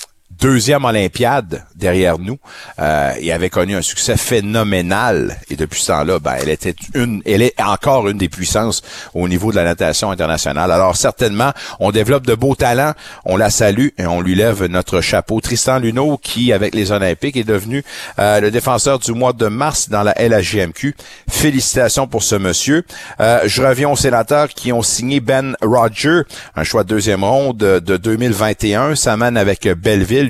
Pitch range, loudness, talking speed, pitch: 95-130 Hz, -15 LUFS, 180 wpm, 110 Hz